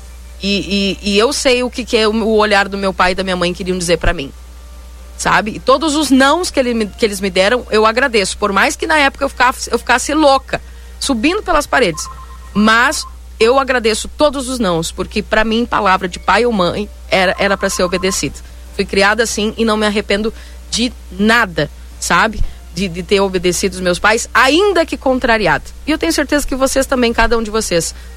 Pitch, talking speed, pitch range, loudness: 220 Hz, 205 wpm, 190-260 Hz, -14 LUFS